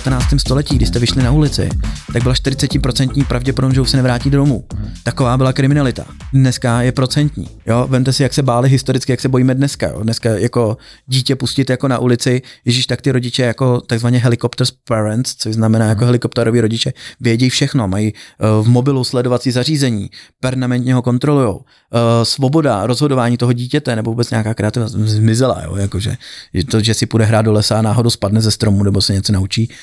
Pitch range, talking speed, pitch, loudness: 110-130 Hz, 190 wpm, 125 Hz, -15 LUFS